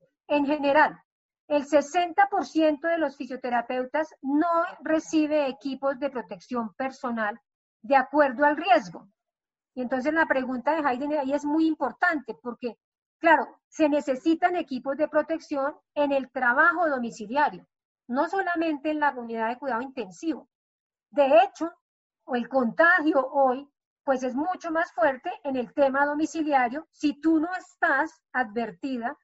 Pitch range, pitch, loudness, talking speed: 260-320 Hz, 290 Hz, -25 LUFS, 135 wpm